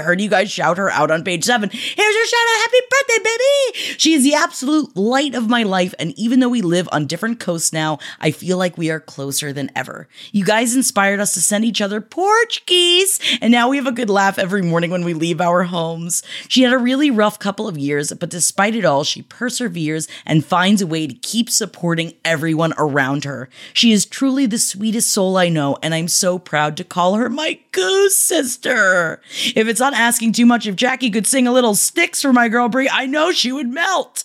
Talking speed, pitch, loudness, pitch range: 225 wpm, 215 Hz, -16 LUFS, 170-260 Hz